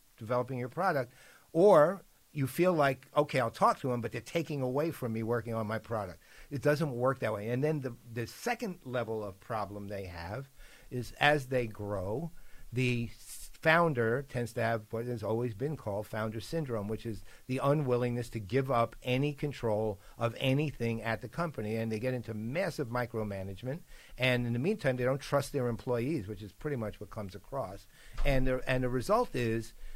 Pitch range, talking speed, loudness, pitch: 110-135 Hz, 190 wpm, -33 LUFS, 125 Hz